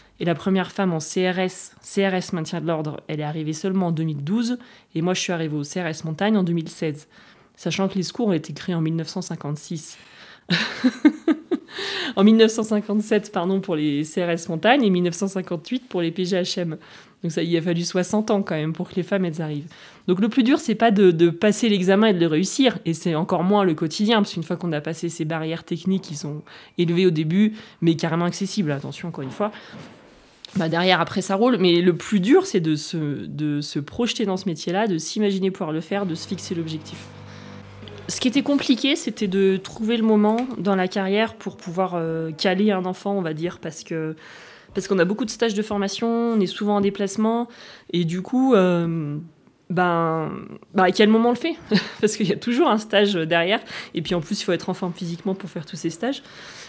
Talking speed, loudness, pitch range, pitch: 210 wpm, -22 LUFS, 165-210 Hz, 185 Hz